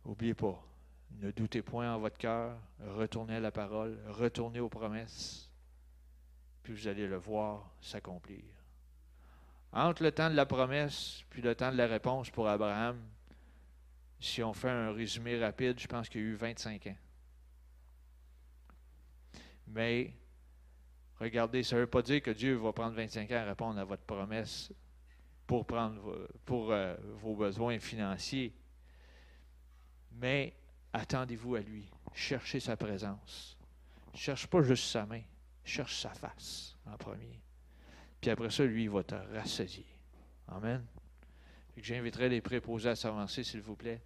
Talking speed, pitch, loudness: 155 wpm, 105 Hz, -37 LUFS